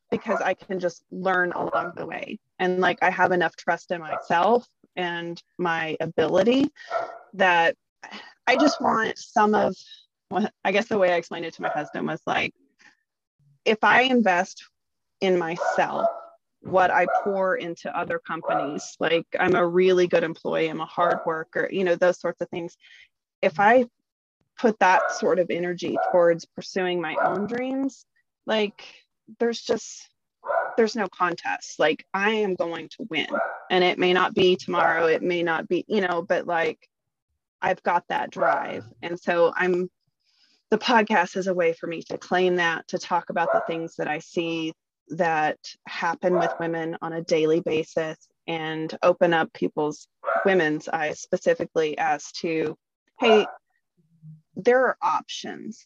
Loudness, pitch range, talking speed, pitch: -24 LUFS, 165-210 Hz, 160 wpm, 180 Hz